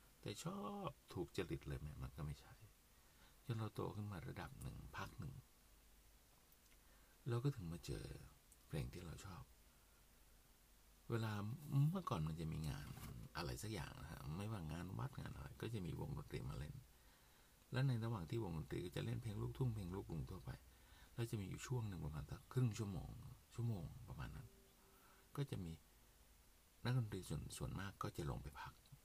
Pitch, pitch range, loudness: 105 Hz, 80-120 Hz, -48 LUFS